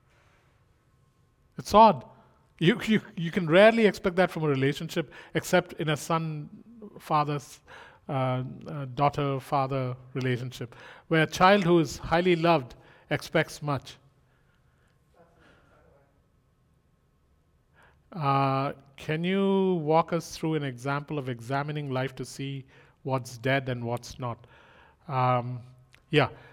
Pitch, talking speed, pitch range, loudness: 145 Hz, 115 wpm, 130-165 Hz, -27 LUFS